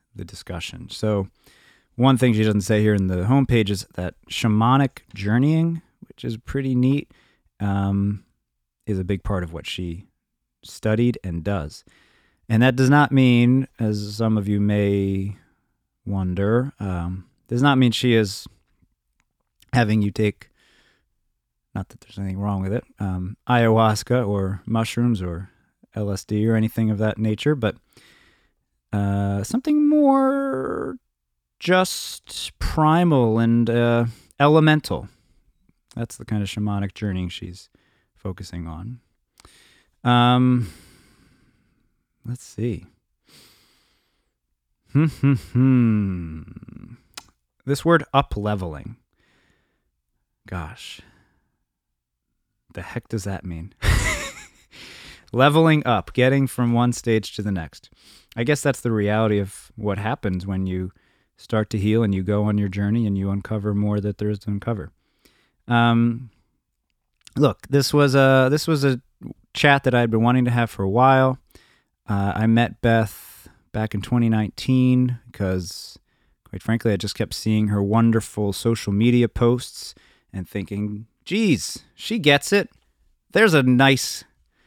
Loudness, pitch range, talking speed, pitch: -21 LUFS, 100-125 Hz, 130 wpm, 110 Hz